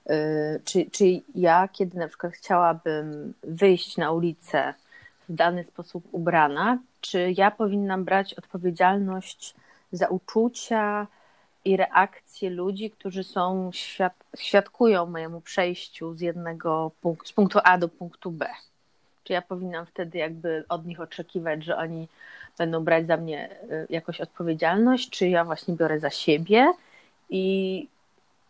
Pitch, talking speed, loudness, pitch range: 180 Hz, 130 wpm, -25 LUFS, 165-195 Hz